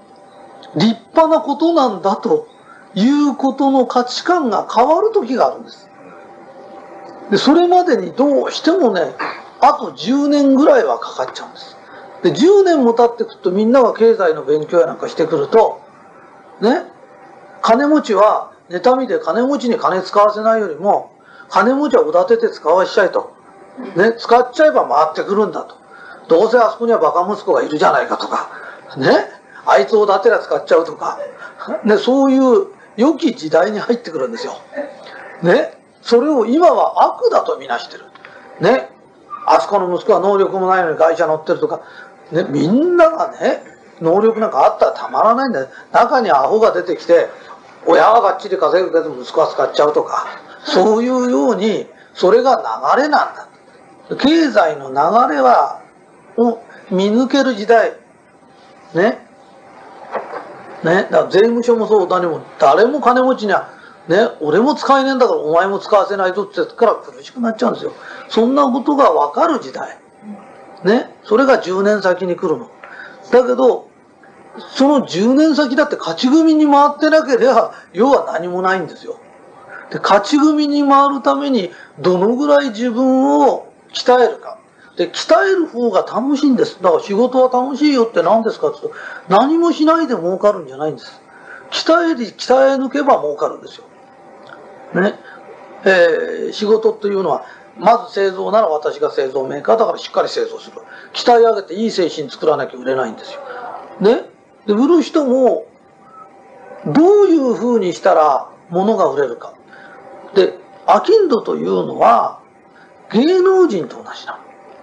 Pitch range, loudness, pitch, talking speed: 220-325 Hz, -14 LUFS, 260 Hz, 310 characters per minute